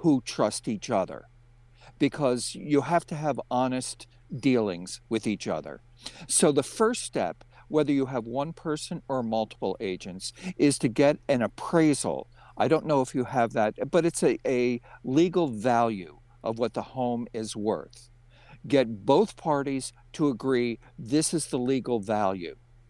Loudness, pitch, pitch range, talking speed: -27 LUFS, 130 Hz, 120-145 Hz, 155 wpm